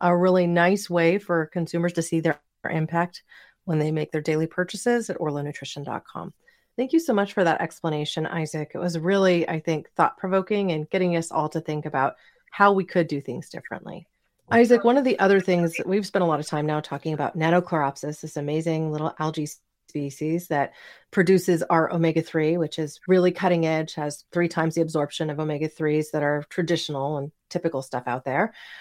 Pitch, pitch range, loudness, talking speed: 165 Hz, 155-180 Hz, -24 LUFS, 195 wpm